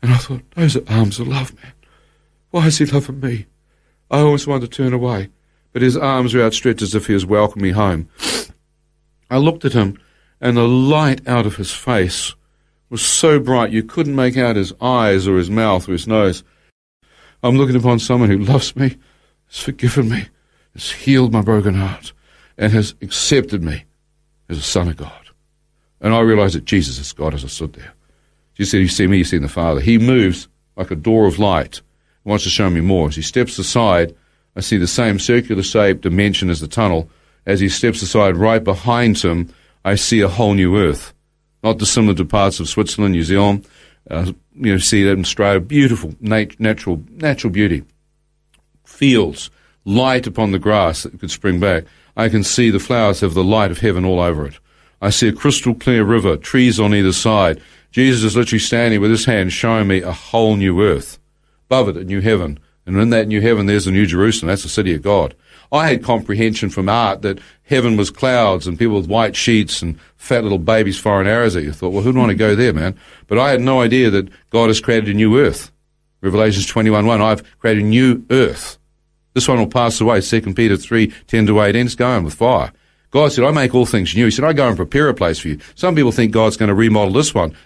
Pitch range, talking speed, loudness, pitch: 95-125 Hz, 220 wpm, -15 LUFS, 110 Hz